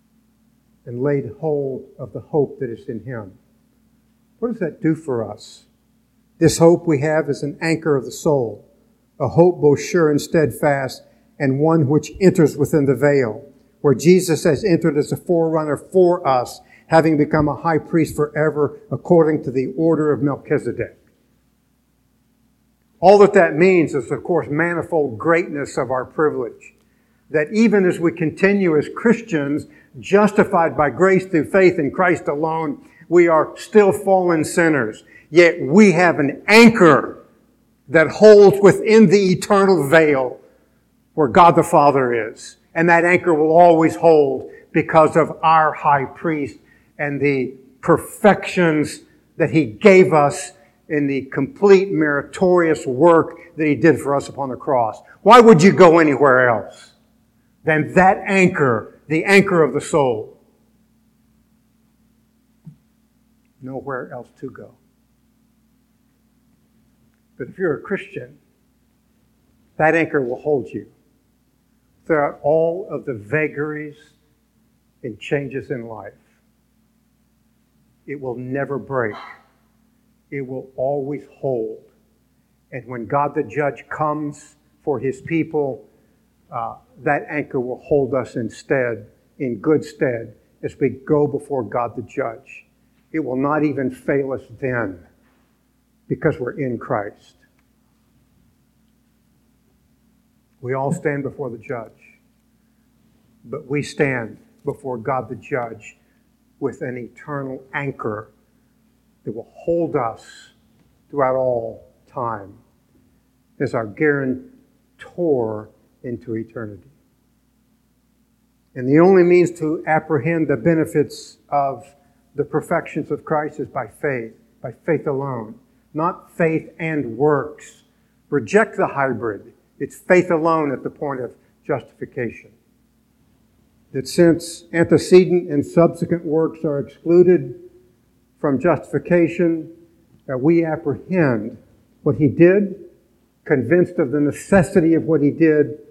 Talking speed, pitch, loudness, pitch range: 125 wpm, 155 Hz, -17 LUFS, 140-175 Hz